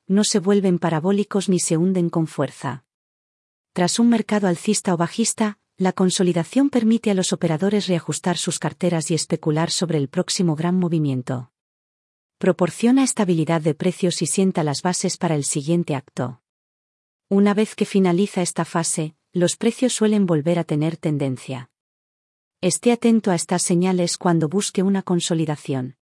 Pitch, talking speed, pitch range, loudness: 175 Hz, 150 wpm, 160-195 Hz, -21 LUFS